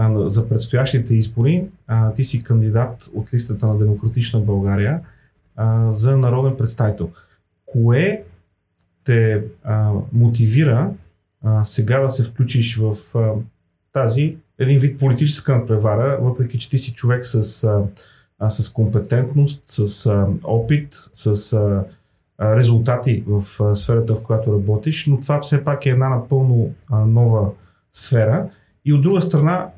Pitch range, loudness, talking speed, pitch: 110-135 Hz, -18 LUFS, 135 wpm, 115 Hz